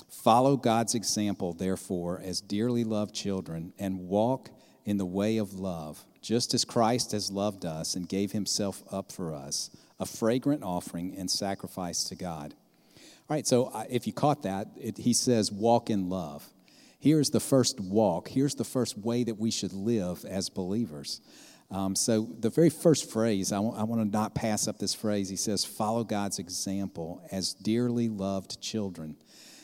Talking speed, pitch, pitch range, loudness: 175 wpm, 105 Hz, 95-115 Hz, -29 LUFS